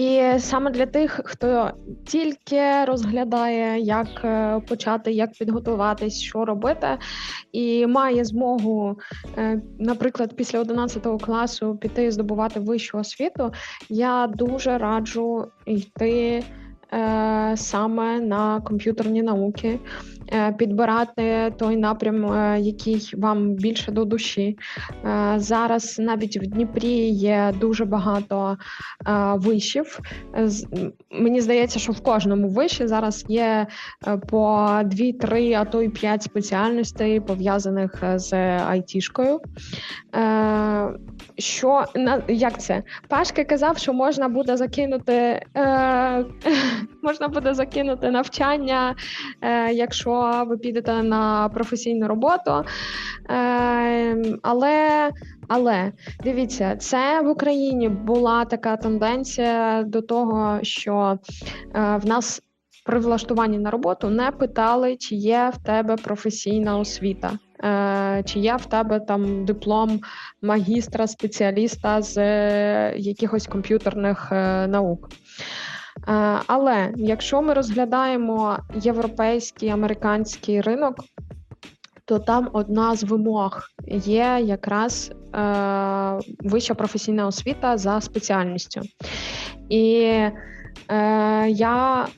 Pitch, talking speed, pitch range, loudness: 225 Hz, 95 wpm, 210-240 Hz, -22 LUFS